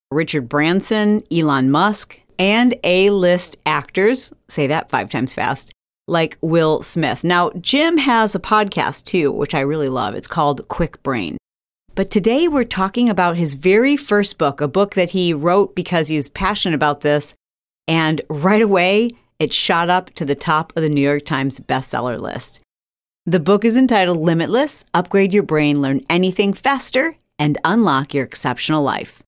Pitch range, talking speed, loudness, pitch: 150-205 Hz, 165 wpm, -17 LUFS, 175 Hz